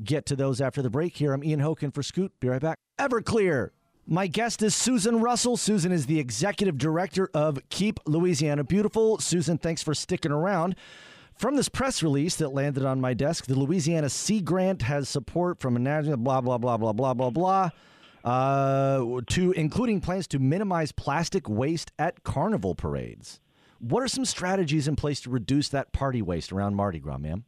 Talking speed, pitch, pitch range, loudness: 185 wpm, 150 Hz, 135-180 Hz, -26 LUFS